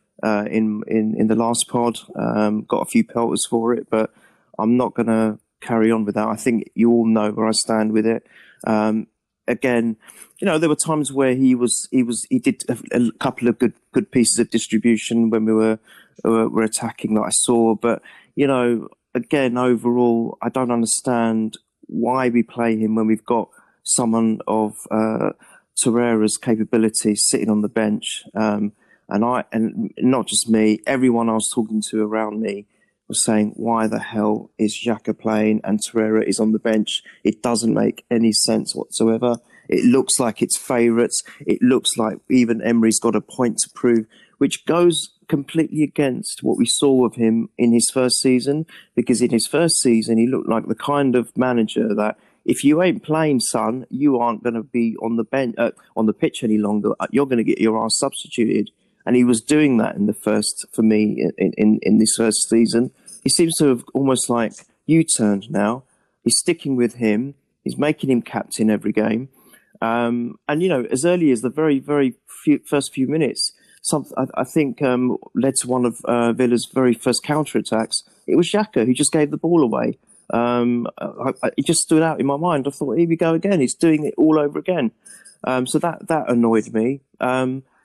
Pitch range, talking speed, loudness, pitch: 110-130 Hz, 200 wpm, -19 LUFS, 120 Hz